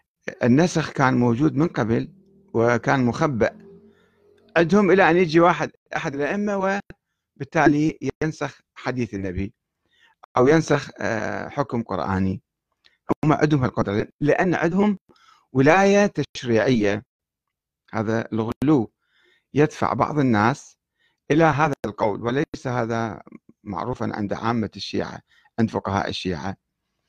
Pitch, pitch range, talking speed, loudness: 140 Hz, 115-165 Hz, 100 wpm, -22 LUFS